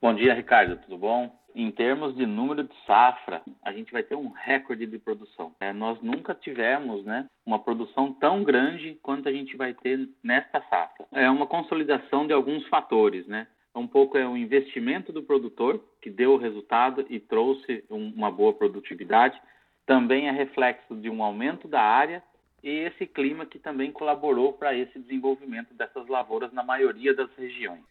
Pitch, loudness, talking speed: 140 Hz, -26 LUFS, 175 wpm